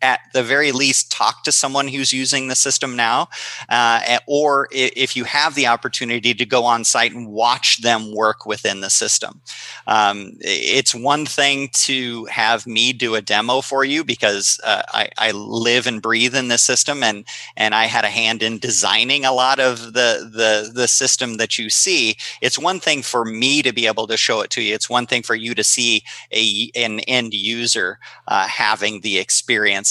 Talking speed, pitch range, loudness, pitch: 195 wpm, 115-130 Hz, -16 LUFS, 120 Hz